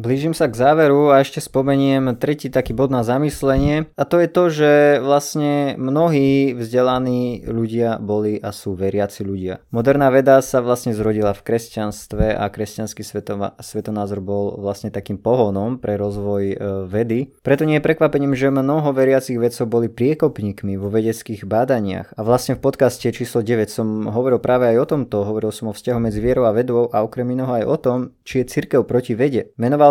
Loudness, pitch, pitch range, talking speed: -18 LUFS, 120 Hz, 105-135 Hz, 180 wpm